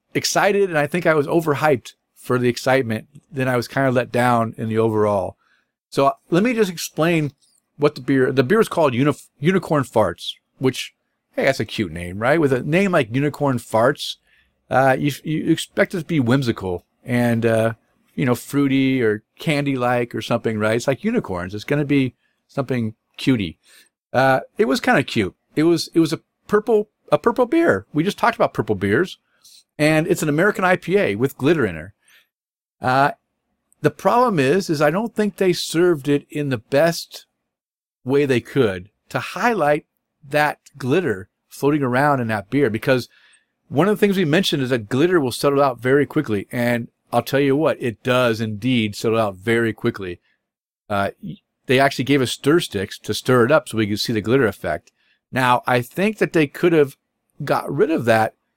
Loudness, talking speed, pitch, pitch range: -20 LUFS, 195 wpm, 135 Hz, 115-155 Hz